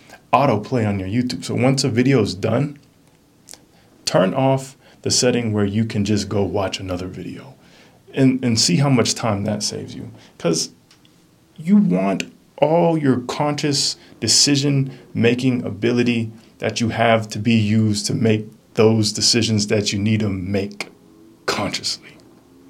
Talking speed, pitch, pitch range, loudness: 150 wpm, 115 Hz, 105-135 Hz, -19 LUFS